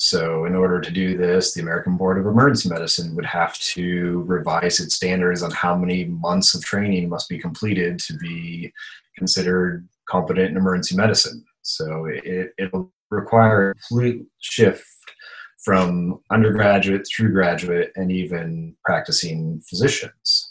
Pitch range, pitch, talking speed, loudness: 85-95 Hz, 90 Hz, 145 wpm, -20 LUFS